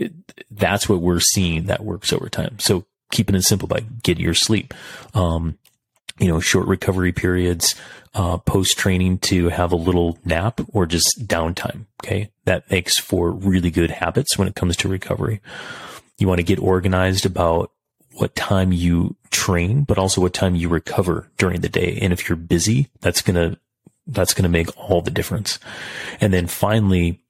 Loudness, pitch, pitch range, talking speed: -19 LUFS, 95 Hz, 85-100 Hz, 180 wpm